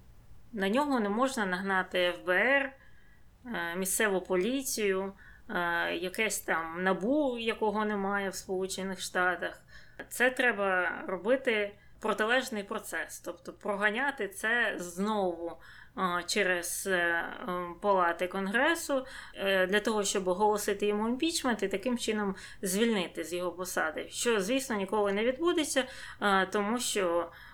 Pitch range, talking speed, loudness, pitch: 185-230 Hz, 105 wpm, -30 LUFS, 205 Hz